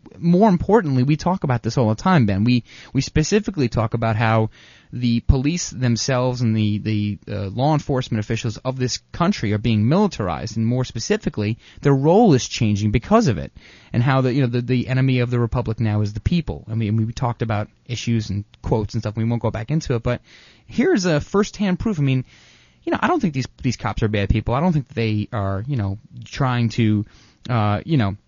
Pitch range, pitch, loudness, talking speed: 110-135 Hz, 120 Hz, -20 LUFS, 225 wpm